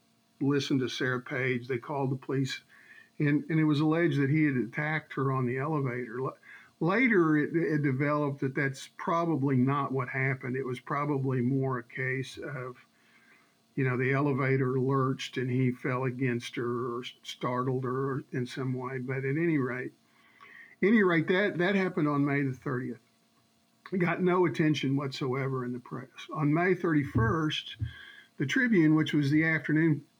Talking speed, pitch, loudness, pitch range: 165 wpm, 135 Hz, -29 LUFS, 130-155 Hz